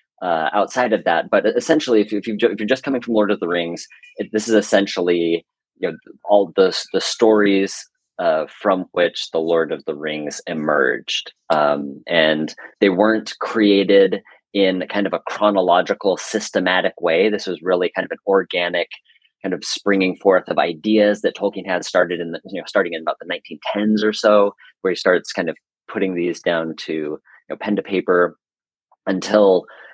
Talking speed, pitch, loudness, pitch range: 185 wpm, 100 Hz, -19 LUFS, 85-105 Hz